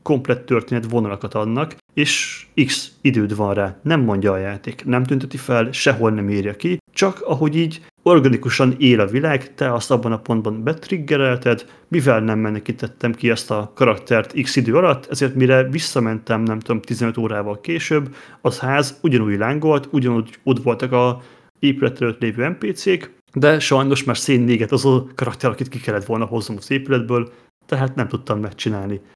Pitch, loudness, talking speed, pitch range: 125 Hz, -19 LUFS, 165 wpm, 115-140 Hz